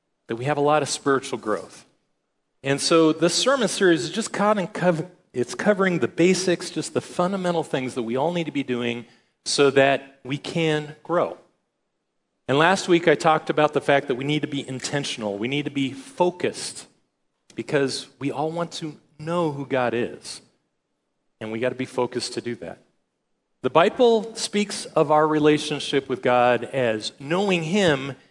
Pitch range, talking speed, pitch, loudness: 130-170 Hz, 175 wpm, 150 Hz, -23 LUFS